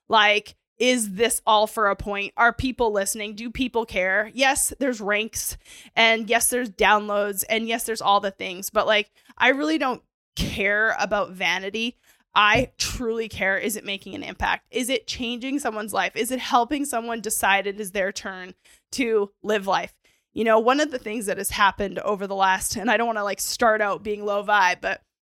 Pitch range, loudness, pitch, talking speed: 200-235 Hz, -22 LUFS, 215 Hz, 195 wpm